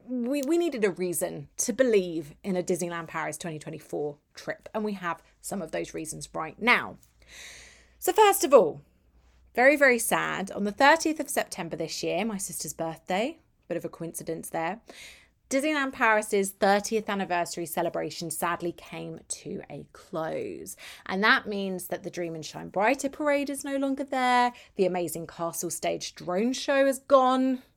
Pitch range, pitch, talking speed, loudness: 170-260 Hz, 195 Hz, 165 wpm, -27 LUFS